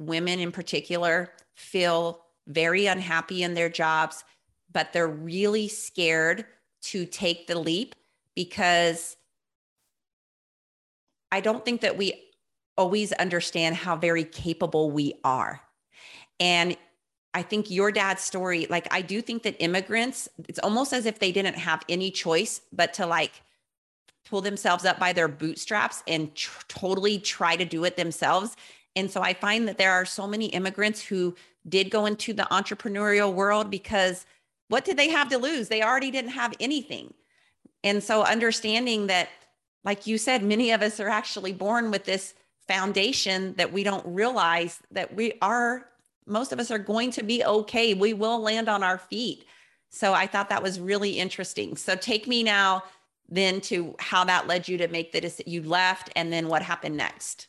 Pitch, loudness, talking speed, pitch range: 190 Hz, -26 LUFS, 170 wpm, 175-215 Hz